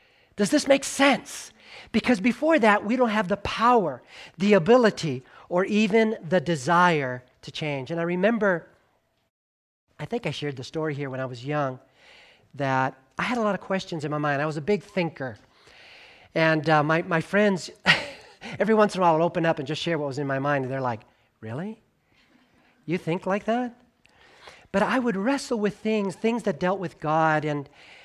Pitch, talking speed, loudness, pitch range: 175 Hz, 195 wpm, -24 LUFS, 150-210 Hz